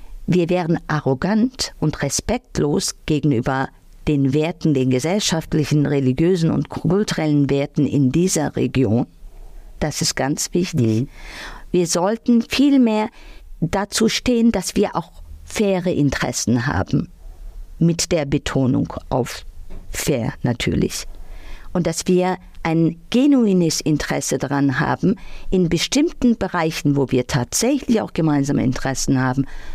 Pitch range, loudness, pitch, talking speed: 135-185 Hz, -19 LUFS, 155 Hz, 115 wpm